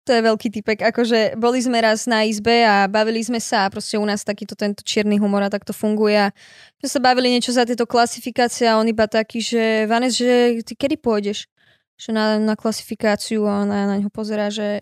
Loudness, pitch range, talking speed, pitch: -19 LUFS, 210-240 Hz, 215 wpm, 220 Hz